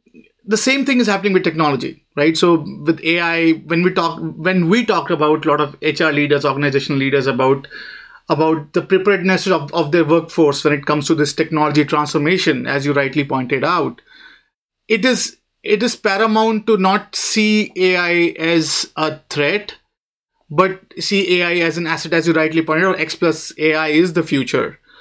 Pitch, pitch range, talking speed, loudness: 165 Hz, 150-185 Hz, 180 wpm, -16 LUFS